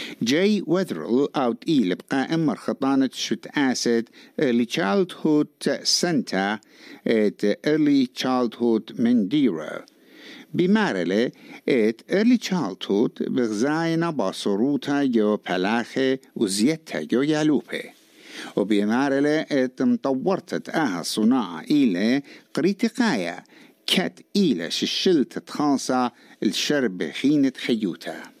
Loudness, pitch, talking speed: -23 LUFS, 165 Hz, 85 wpm